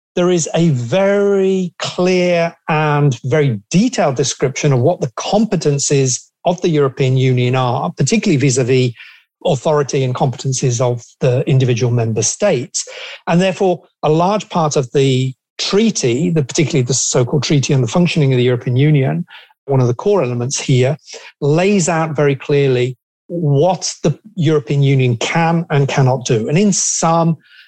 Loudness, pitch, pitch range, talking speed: -15 LUFS, 150 Hz, 130-175 Hz, 150 wpm